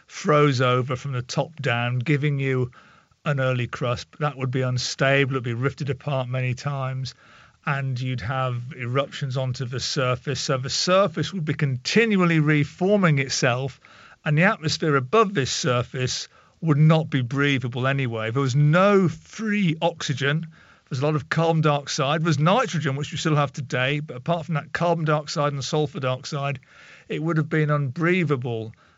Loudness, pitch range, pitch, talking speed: -23 LUFS, 130-155 Hz, 145 Hz, 165 wpm